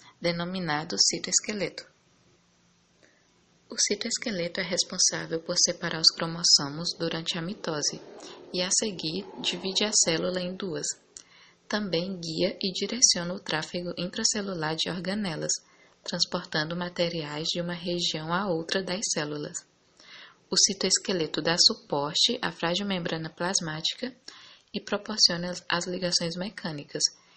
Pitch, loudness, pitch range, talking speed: 175 Hz, -26 LUFS, 165-195 Hz, 115 wpm